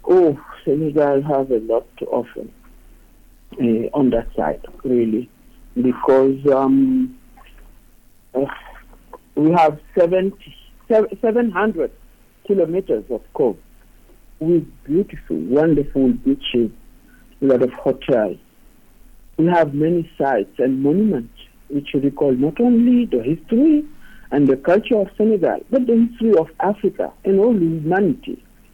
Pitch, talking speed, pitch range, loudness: 160 Hz, 115 wpm, 135-215 Hz, -18 LUFS